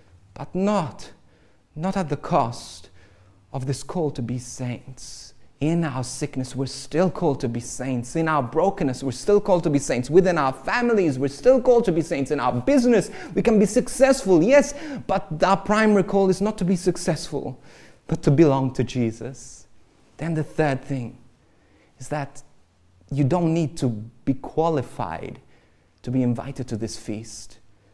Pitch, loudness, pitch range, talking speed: 140 Hz, -22 LUFS, 120-180 Hz, 170 wpm